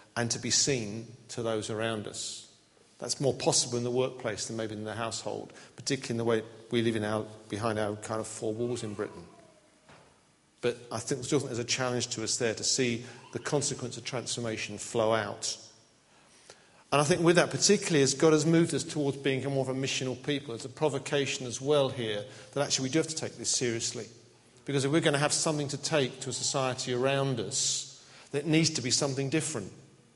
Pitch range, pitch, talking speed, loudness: 115-140 Hz, 125 Hz, 210 wpm, -30 LUFS